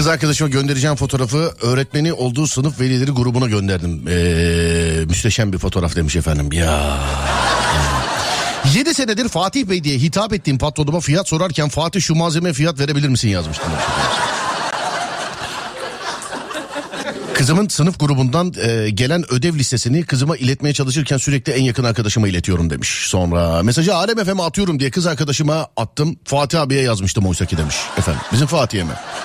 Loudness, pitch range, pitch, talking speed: -17 LUFS, 100-160 Hz, 135 Hz, 135 wpm